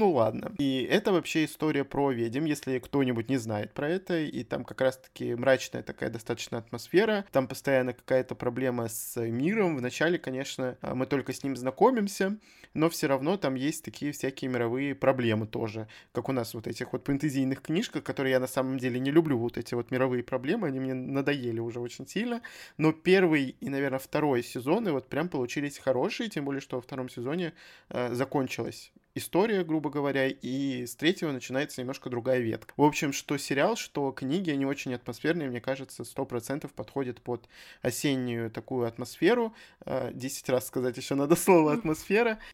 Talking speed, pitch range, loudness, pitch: 175 wpm, 125-150 Hz, -30 LUFS, 135 Hz